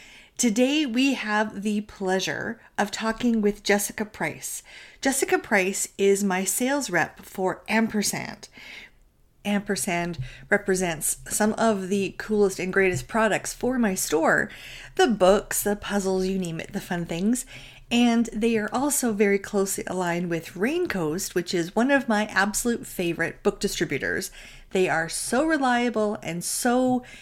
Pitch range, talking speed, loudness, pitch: 185-230 Hz, 140 wpm, -24 LUFS, 205 Hz